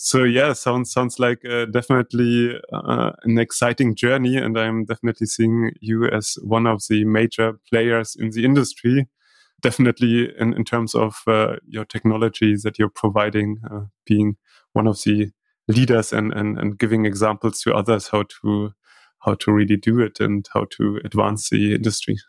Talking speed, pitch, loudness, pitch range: 165 wpm, 110 Hz, -20 LUFS, 105-120 Hz